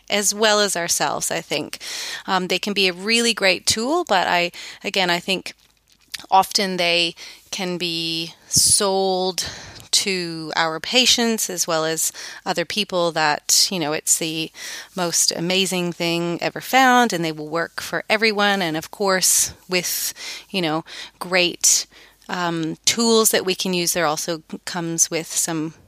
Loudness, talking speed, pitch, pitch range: -19 LUFS, 155 wpm, 180 Hz, 165-200 Hz